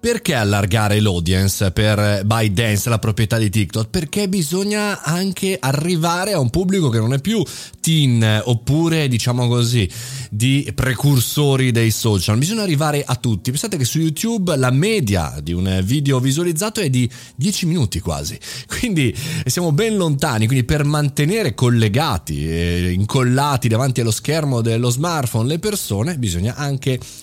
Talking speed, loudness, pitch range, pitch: 145 wpm, -18 LUFS, 110-160 Hz, 130 Hz